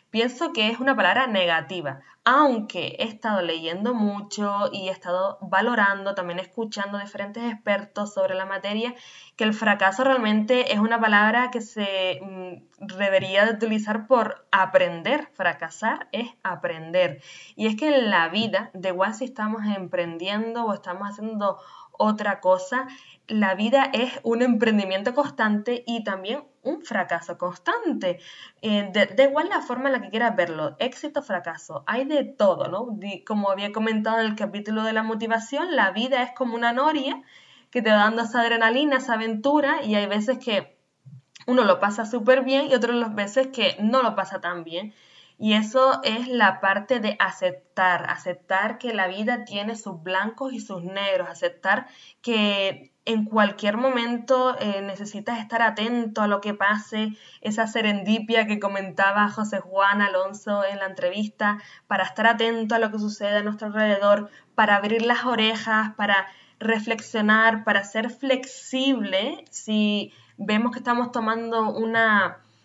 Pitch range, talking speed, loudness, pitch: 195-240 Hz, 155 wpm, -23 LUFS, 215 Hz